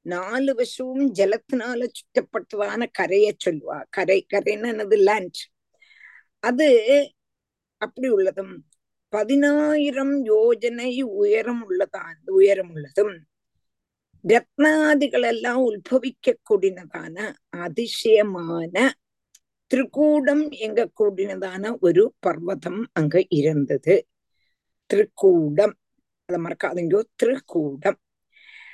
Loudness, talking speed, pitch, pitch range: -21 LUFS, 65 wpm, 230 Hz, 190-290 Hz